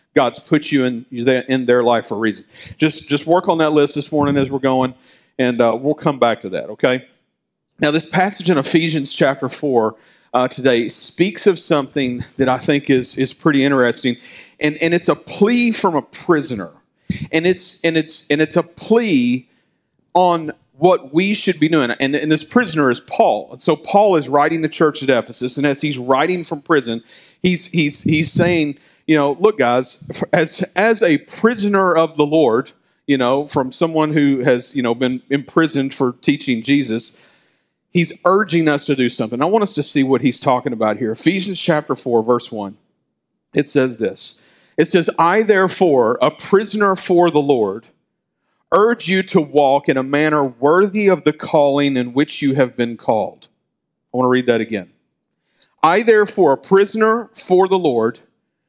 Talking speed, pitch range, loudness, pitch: 185 wpm, 130-175 Hz, -17 LUFS, 150 Hz